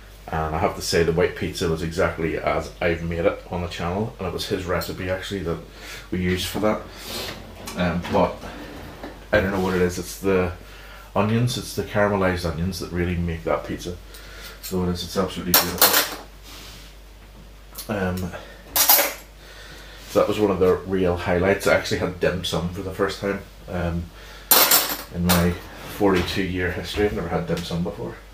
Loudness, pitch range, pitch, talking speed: -22 LUFS, 85-100 Hz, 90 Hz, 180 wpm